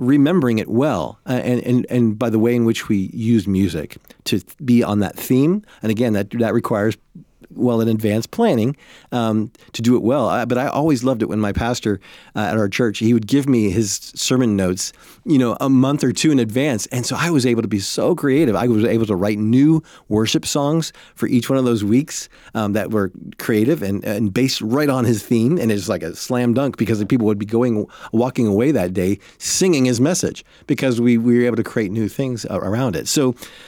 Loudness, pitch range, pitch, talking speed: -18 LUFS, 110-130 Hz, 120 Hz, 230 wpm